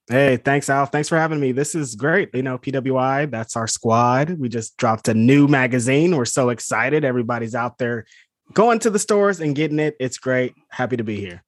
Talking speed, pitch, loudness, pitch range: 215 wpm, 130 Hz, -19 LUFS, 120-145 Hz